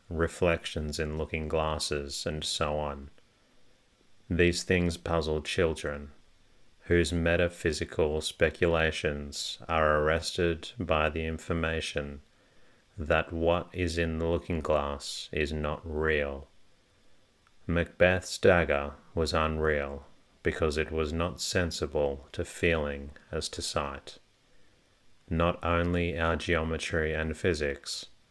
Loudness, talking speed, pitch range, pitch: -30 LUFS, 105 wpm, 75-85 Hz, 80 Hz